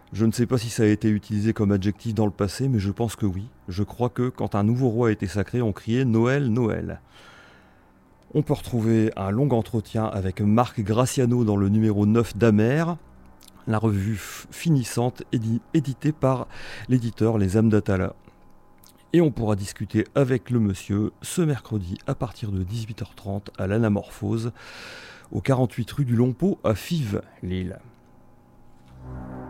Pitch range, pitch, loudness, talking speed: 100-125 Hz, 110 Hz, -24 LUFS, 160 wpm